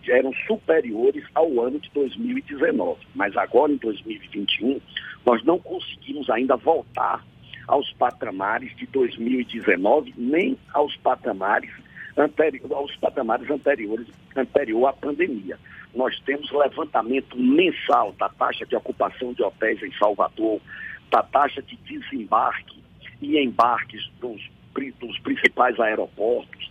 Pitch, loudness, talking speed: 160 Hz, -23 LUFS, 115 wpm